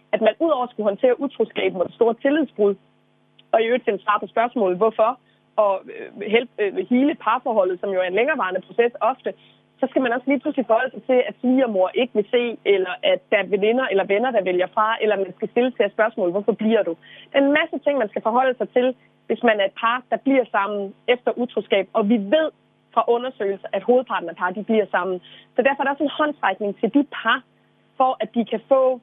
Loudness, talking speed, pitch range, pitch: -21 LUFS, 225 wpm, 205-260 Hz, 225 Hz